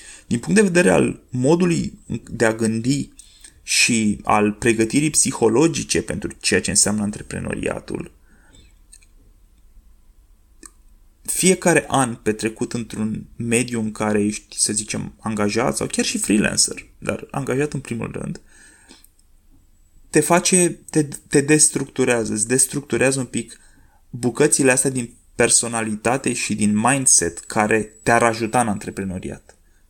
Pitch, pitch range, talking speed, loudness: 115 Hz, 100-135 Hz, 120 wpm, -19 LUFS